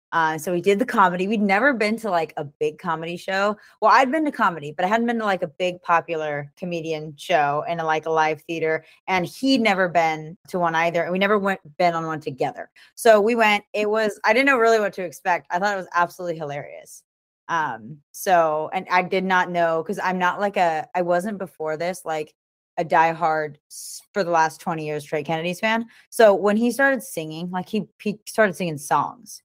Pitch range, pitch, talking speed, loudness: 160-205 Hz, 180 Hz, 220 wpm, -22 LUFS